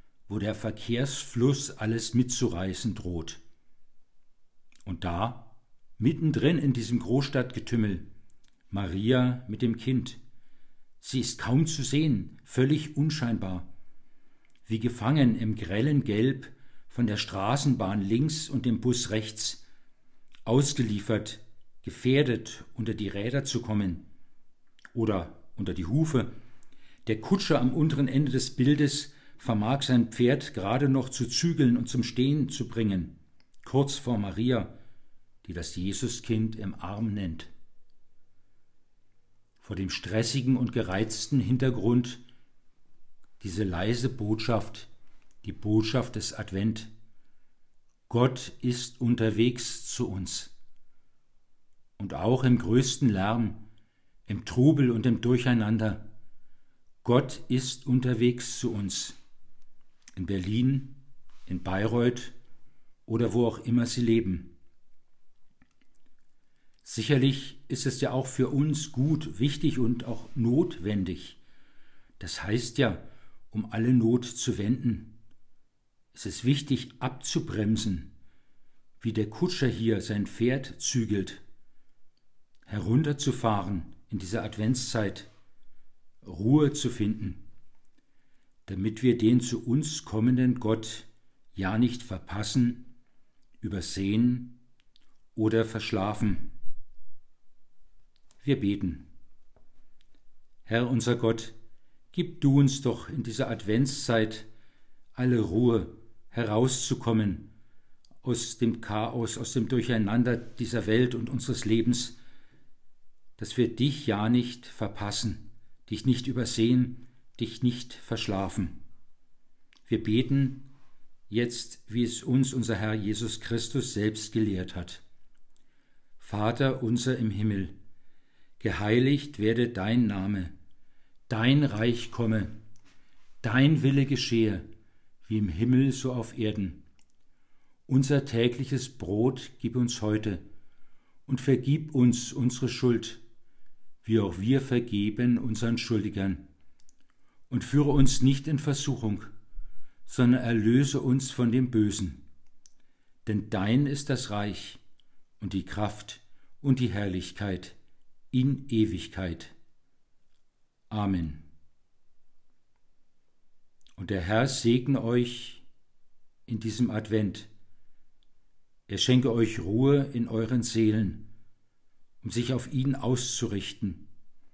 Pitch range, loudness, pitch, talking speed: 105-125 Hz, -28 LUFS, 115 Hz, 105 wpm